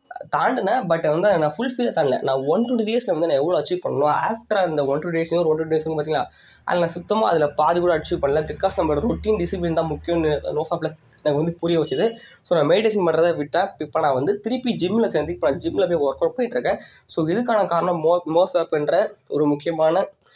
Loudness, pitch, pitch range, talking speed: -21 LUFS, 170 Hz, 155-210 Hz, 205 wpm